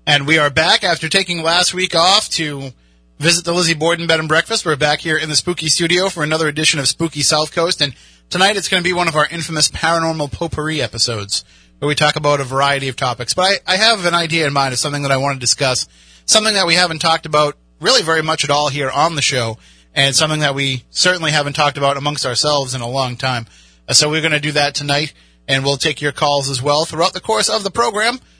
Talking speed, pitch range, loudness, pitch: 245 wpm, 140-165 Hz, -15 LUFS, 150 Hz